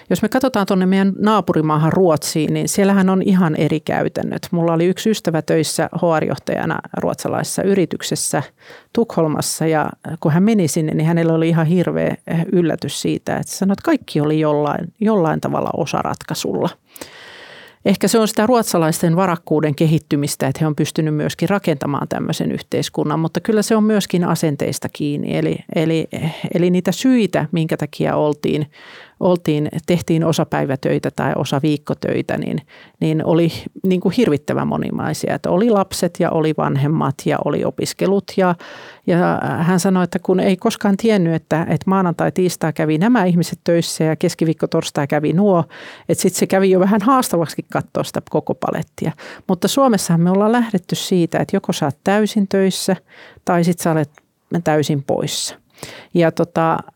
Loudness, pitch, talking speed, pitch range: -18 LUFS, 175 Hz, 155 wpm, 160-195 Hz